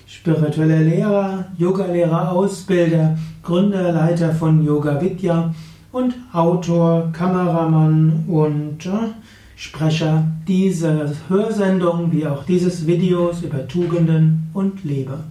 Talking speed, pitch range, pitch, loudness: 95 wpm, 160-180 Hz, 165 Hz, -18 LUFS